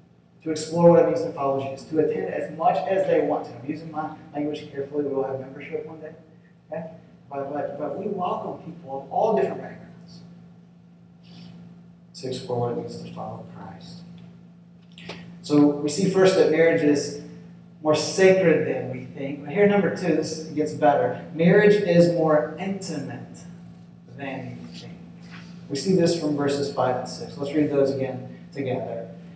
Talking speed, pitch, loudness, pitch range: 175 wpm, 160 Hz, -23 LUFS, 145-175 Hz